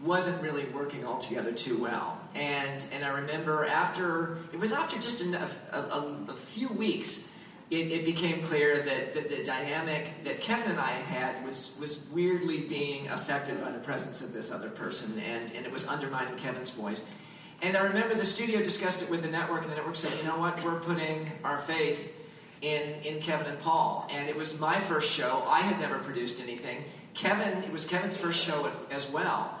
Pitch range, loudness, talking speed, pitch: 145-180 Hz, -31 LUFS, 200 wpm, 155 Hz